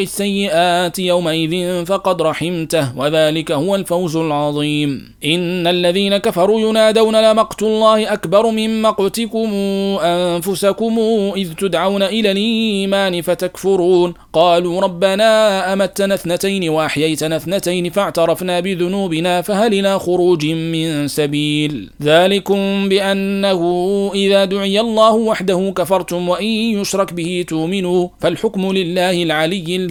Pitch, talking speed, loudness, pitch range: 190 Hz, 100 wpm, -15 LUFS, 175-200 Hz